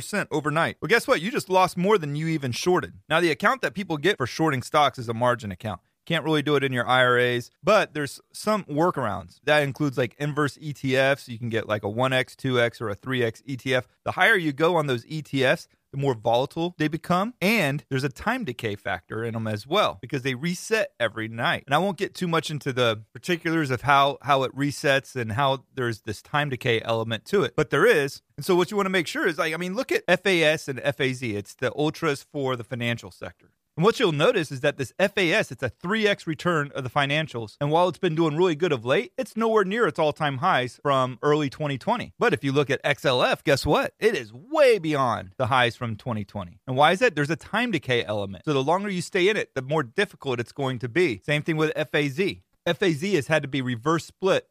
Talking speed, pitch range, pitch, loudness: 235 wpm, 125-170 Hz, 145 Hz, -24 LUFS